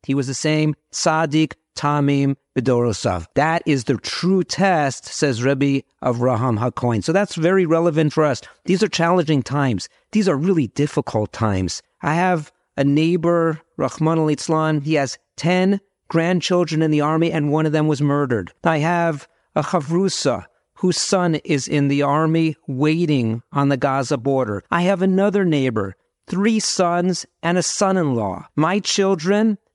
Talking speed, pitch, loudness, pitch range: 155 wpm, 155 Hz, -19 LUFS, 140-175 Hz